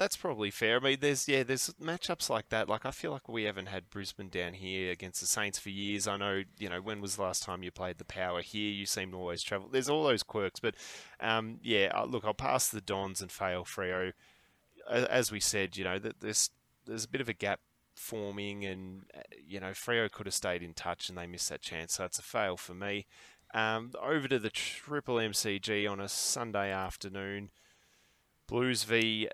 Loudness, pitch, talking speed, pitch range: -34 LUFS, 100 Hz, 215 wpm, 95-110 Hz